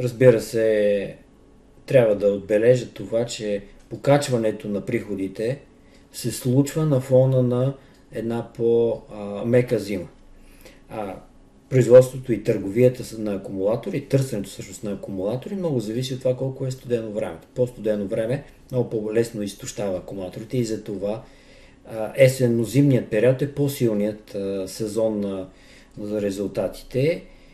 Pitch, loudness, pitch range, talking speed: 115 Hz, -23 LUFS, 105-125 Hz, 120 wpm